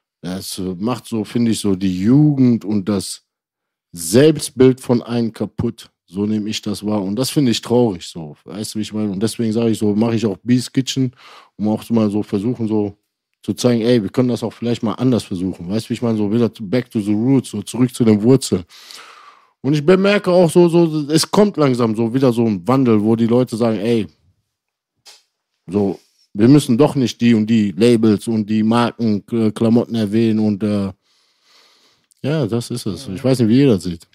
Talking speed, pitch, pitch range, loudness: 205 wpm, 115 Hz, 105-125 Hz, -17 LUFS